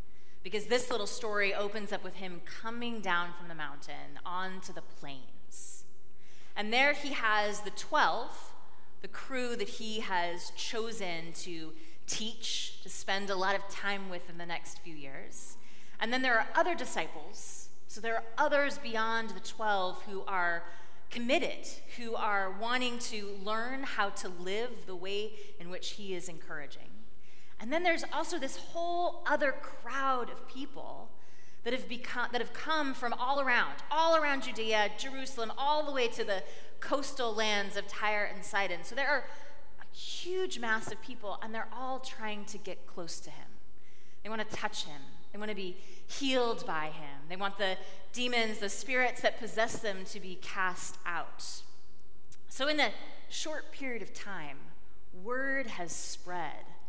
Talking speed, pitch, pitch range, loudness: 170 wpm, 215 Hz, 185-250 Hz, -34 LUFS